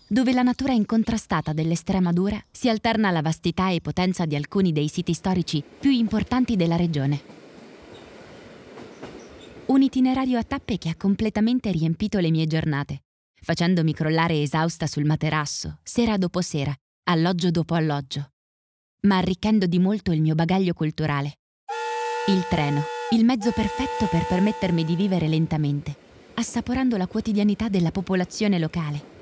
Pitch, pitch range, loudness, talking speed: 180 Hz, 155-215 Hz, -23 LUFS, 140 wpm